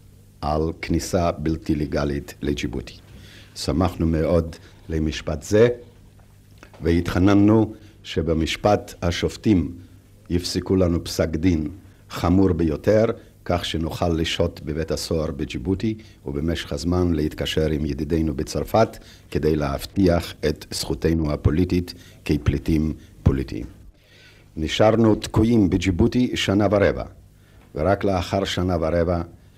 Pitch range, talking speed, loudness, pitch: 80-100 Hz, 95 wpm, -22 LUFS, 90 Hz